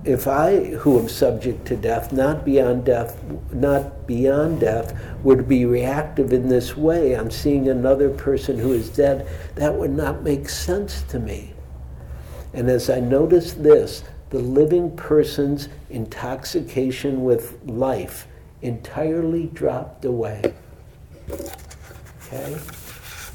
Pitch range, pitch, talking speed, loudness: 115-145 Hz, 130 Hz, 125 wpm, -20 LUFS